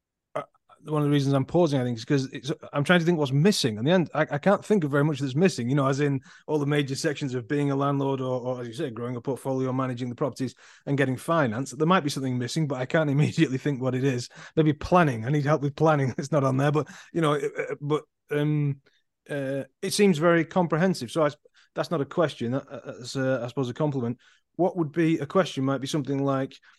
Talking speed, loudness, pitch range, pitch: 250 wpm, -26 LUFS, 135-160 Hz, 145 Hz